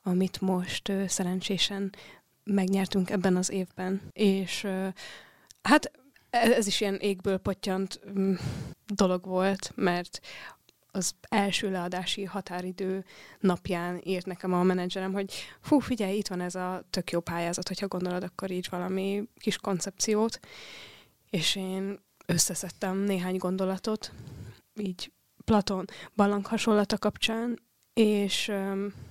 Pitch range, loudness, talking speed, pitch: 185-200 Hz, -29 LUFS, 120 wpm, 190 Hz